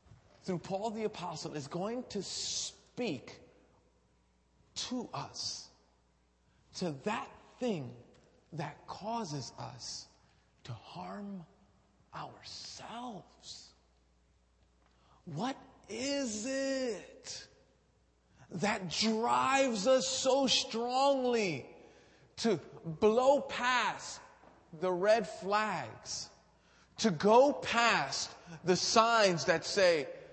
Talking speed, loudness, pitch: 80 wpm, -33 LUFS, 195 Hz